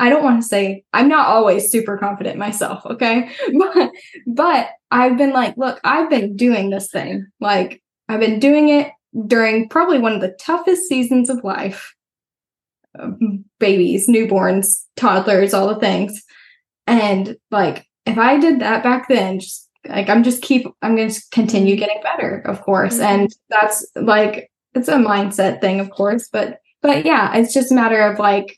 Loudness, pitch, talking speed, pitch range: -16 LUFS, 225 Hz, 175 wpm, 200-260 Hz